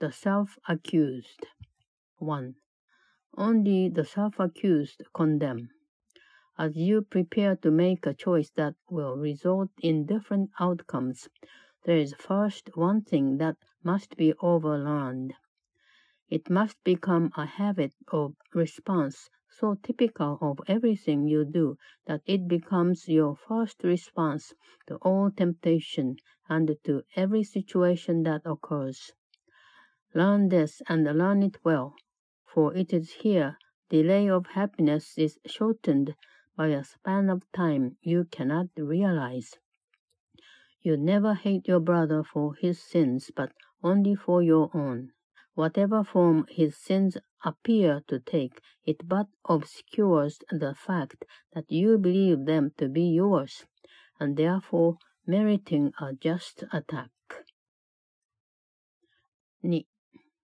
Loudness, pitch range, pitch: -27 LUFS, 150-195 Hz, 165 Hz